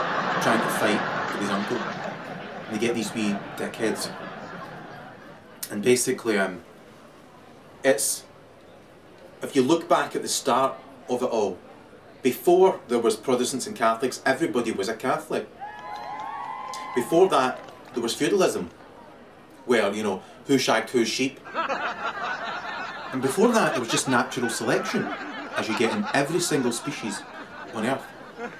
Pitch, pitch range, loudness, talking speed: 125 Hz, 110-130 Hz, -25 LUFS, 135 wpm